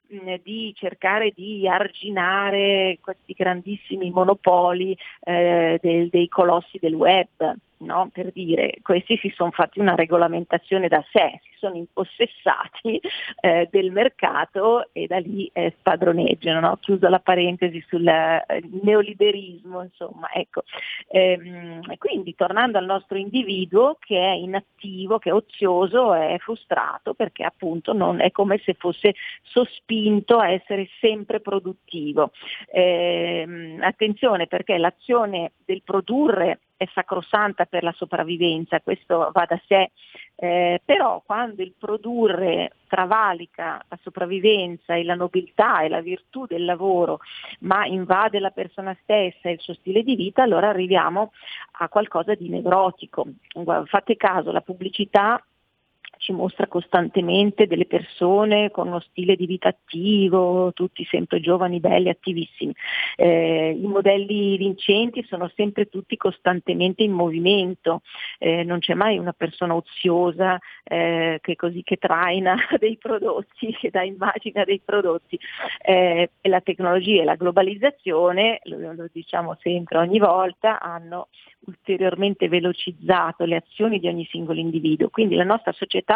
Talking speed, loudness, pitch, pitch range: 135 wpm, -21 LUFS, 185 Hz, 175-205 Hz